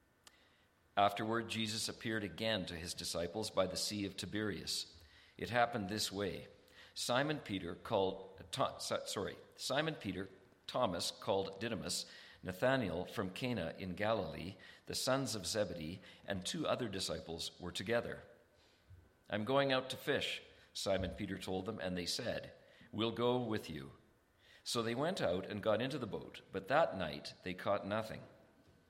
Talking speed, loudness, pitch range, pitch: 150 wpm, -39 LUFS, 90-115 Hz, 100 Hz